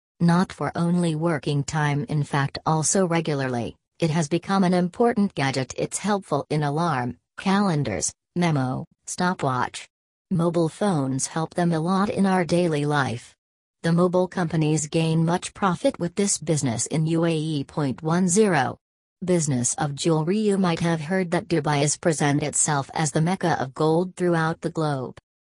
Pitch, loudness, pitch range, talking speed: 160 Hz, -23 LUFS, 145-175 Hz, 150 wpm